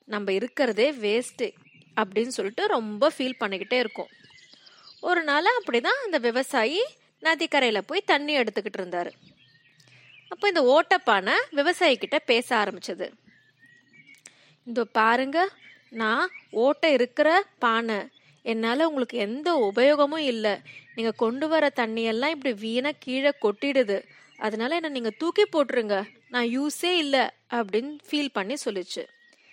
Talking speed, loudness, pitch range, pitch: 115 wpm, -25 LUFS, 225-315 Hz, 260 Hz